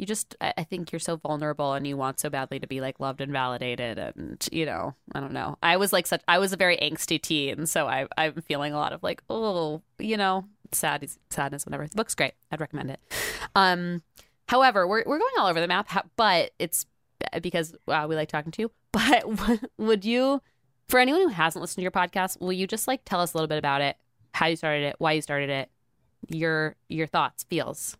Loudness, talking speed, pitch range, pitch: -26 LUFS, 225 wpm, 140-190 Hz, 160 Hz